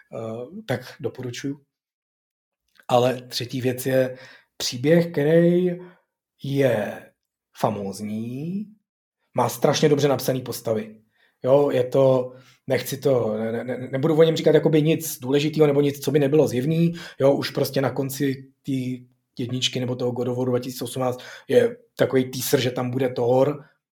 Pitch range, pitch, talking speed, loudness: 125-150 Hz, 130 Hz, 135 wpm, -22 LUFS